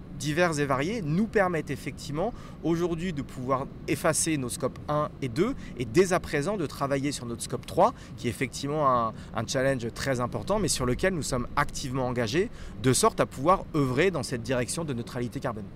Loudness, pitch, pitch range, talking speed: -28 LUFS, 140 Hz, 125-165 Hz, 195 wpm